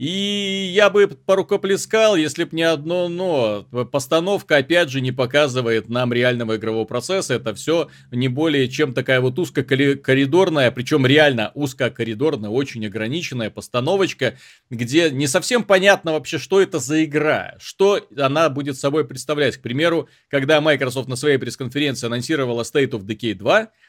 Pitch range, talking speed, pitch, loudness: 125-170 Hz, 145 wpm, 145 Hz, -19 LUFS